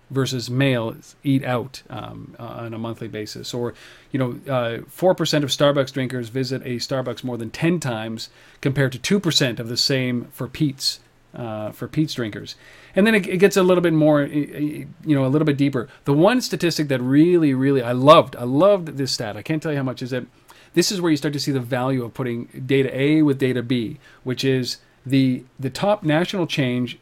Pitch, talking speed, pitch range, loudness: 135 Hz, 215 wpm, 125-150 Hz, -21 LUFS